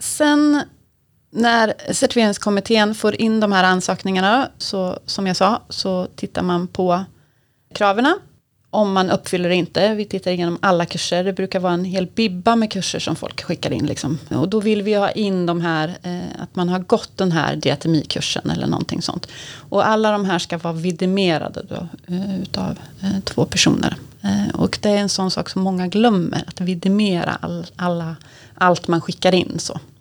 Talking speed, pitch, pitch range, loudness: 175 wpm, 185 Hz, 175-205 Hz, -19 LUFS